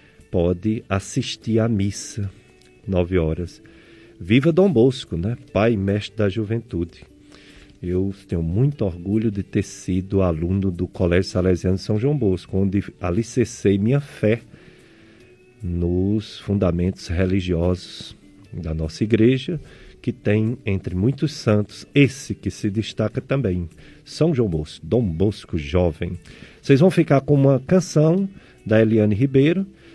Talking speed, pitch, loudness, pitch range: 130 wpm, 105 Hz, -21 LUFS, 90-120 Hz